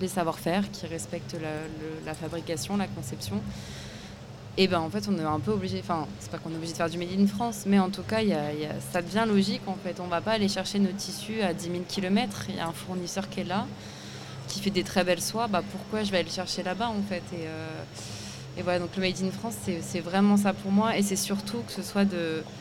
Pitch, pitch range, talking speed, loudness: 185 Hz, 170-200 Hz, 270 wpm, -29 LUFS